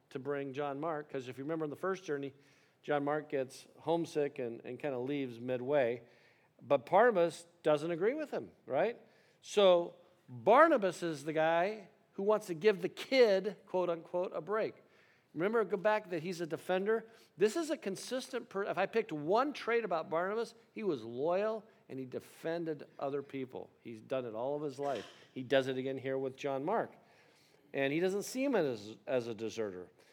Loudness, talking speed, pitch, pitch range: -35 LUFS, 190 wpm, 165 Hz, 135-195 Hz